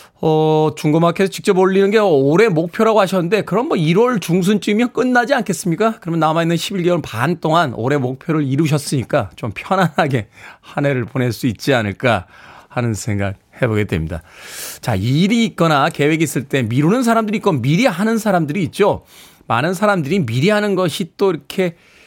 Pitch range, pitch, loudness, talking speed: 135-195 Hz, 165 Hz, -16 LUFS, 365 characters per minute